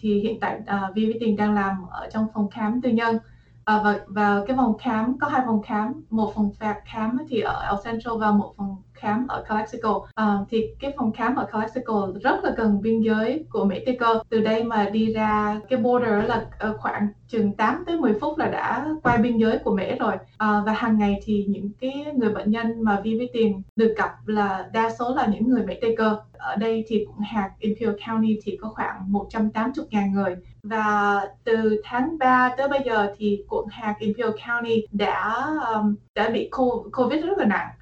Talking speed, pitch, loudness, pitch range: 210 wpm, 220 Hz, -24 LUFS, 210-235 Hz